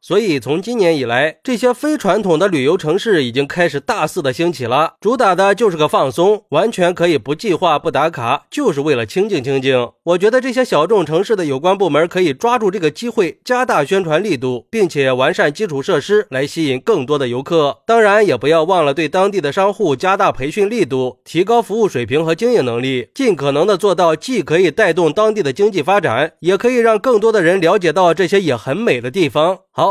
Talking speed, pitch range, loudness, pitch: 330 characters per minute, 145-220 Hz, -15 LUFS, 180 Hz